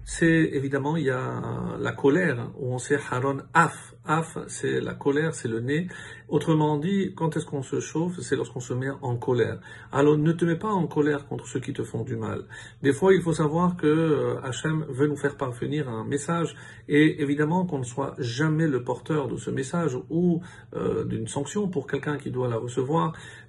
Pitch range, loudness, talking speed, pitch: 135-160 Hz, -26 LUFS, 205 wpm, 145 Hz